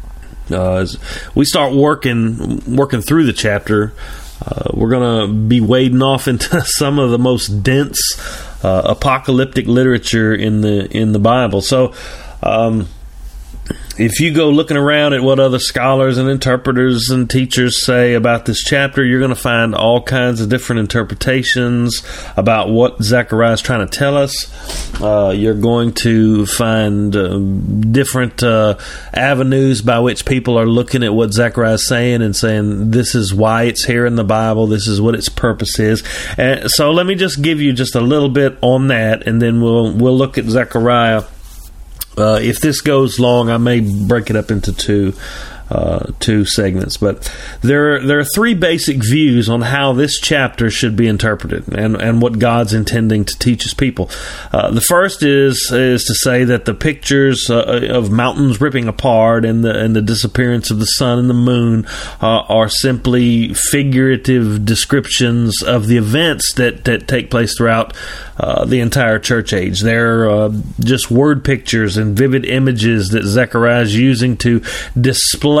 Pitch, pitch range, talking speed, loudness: 120 Hz, 110-130 Hz, 175 wpm, -13 LUFS